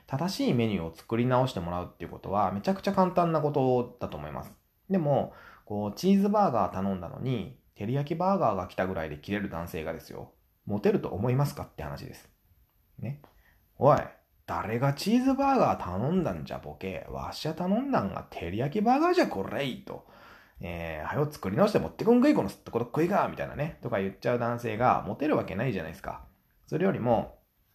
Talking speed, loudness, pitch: 425 characters per minute, -29 LUFS, 120 Hz